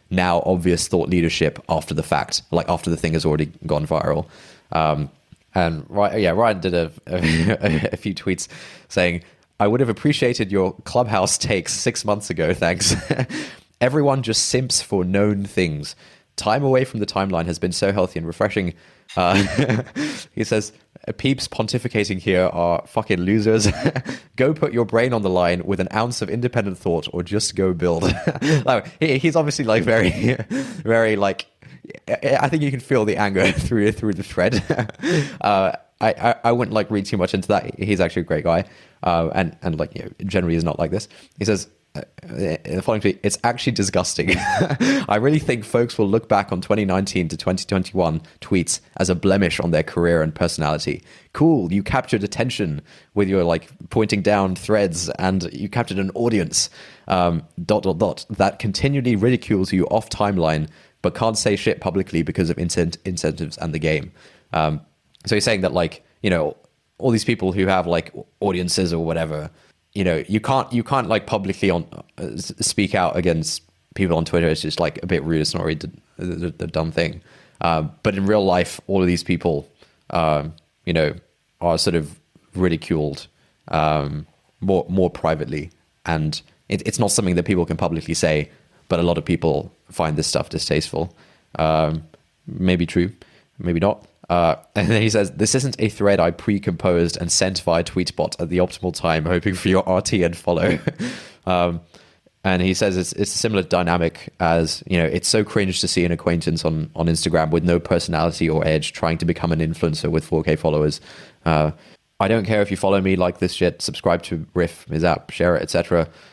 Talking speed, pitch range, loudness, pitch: 185 wpm, 85-105 Hz, -20 LUFS, 90 Hz